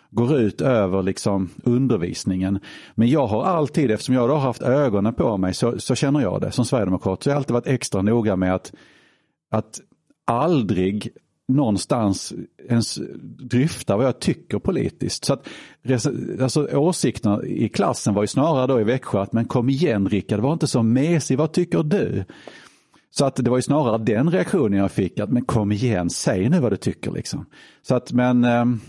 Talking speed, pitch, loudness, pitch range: 185 wpm, 120 Hz, -21 LUFS, 105-135 Hz